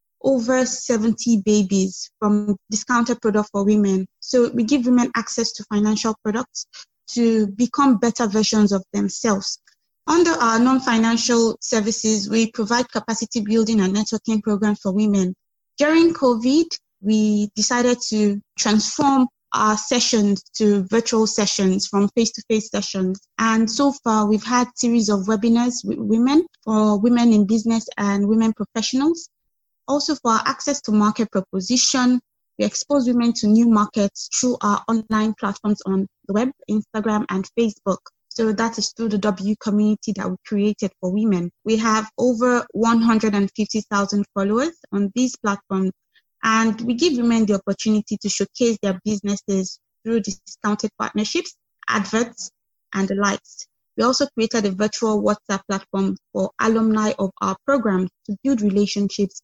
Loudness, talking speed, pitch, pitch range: -20 LUFS, 140 wpm, 220 Hz, 205-235 Hz